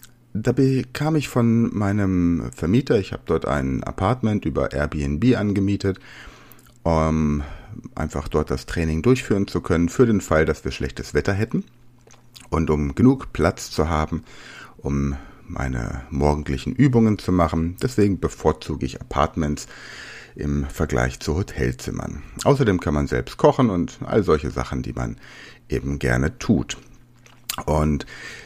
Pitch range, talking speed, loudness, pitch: 75-115 Hz, 135 wpm, -22 LUFS, 85 Hz